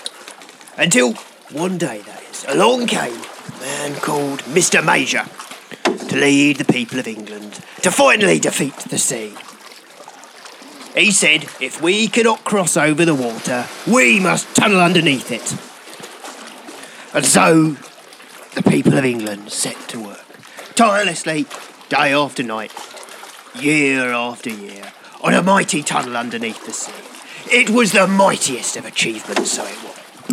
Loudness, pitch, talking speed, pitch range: -16 LUFS, 145 Hz, 135 wpm, 125-180 Hz